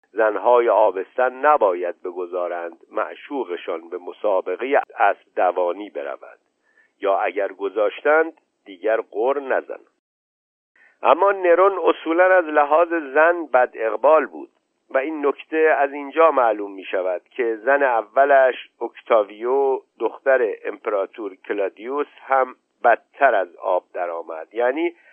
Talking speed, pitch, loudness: 110 wpm, 170 Hz, -20 LUFS